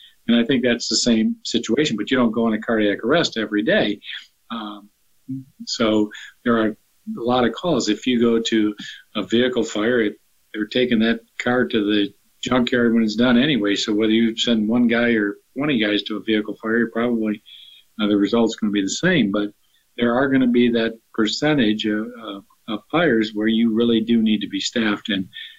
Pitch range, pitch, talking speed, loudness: 105-120 Hz, 115 Hz, 205 wpm, -20 LUFS